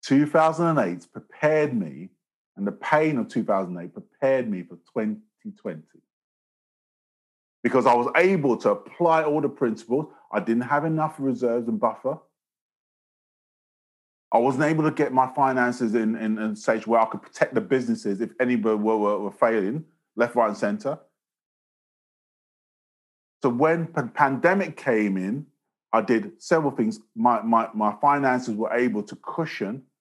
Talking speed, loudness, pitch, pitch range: 150 wpm, -24 LUFS, 125 Hz, 110-155 Hz